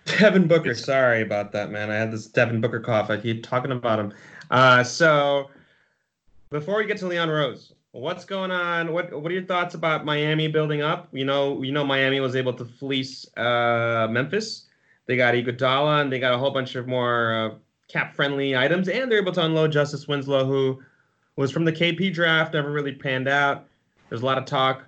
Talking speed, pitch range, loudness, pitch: 205 wpm, 125-160 Hz, -23 LUFS, 140 Hz